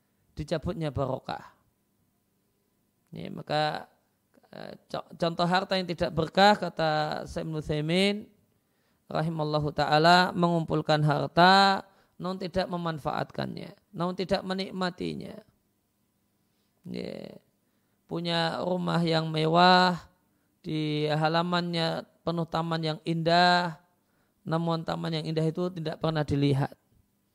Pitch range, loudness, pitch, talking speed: 150-180 Hz, -27 LUFS, 165 Hz, 95 wpm